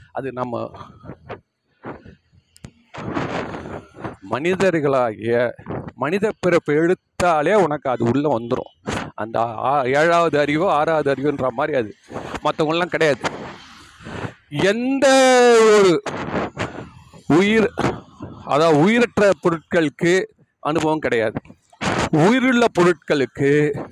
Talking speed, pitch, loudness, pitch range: 75 wpm, 165 Hz, -18 LUFS, 145-200 Hz